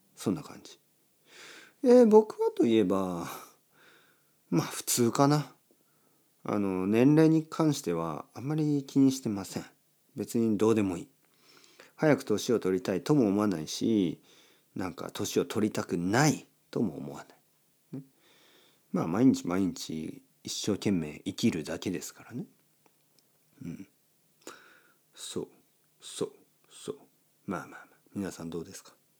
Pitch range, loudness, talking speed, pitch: 95-140 Hz, -29 LUFS, 250 characters per minute, 110 Hz